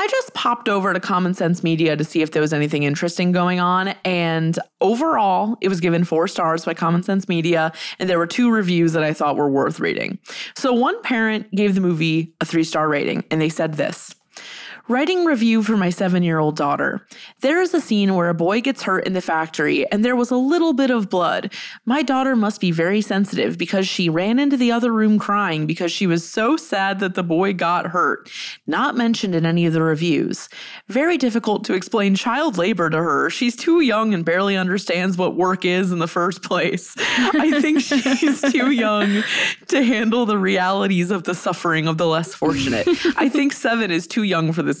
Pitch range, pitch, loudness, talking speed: 170-240 Hz, 195 Hz, -19 LUFS, 210 wpm